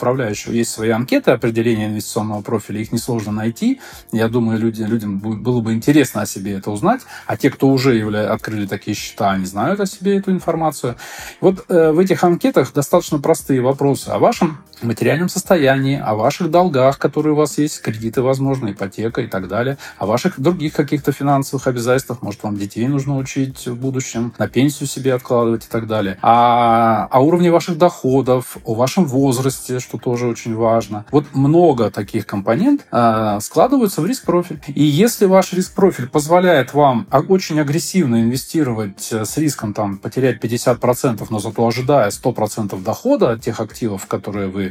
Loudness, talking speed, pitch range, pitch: -17 LUFS, 165 wpm, 115-150 Hz, 125 Hz